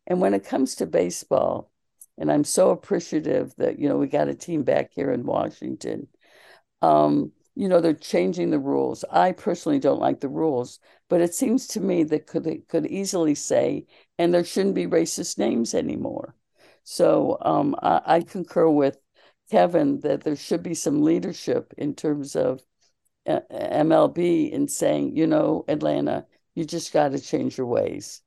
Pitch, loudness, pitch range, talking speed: 165 Hz, -23 LUFS, 145-180 Hz, 170 wpm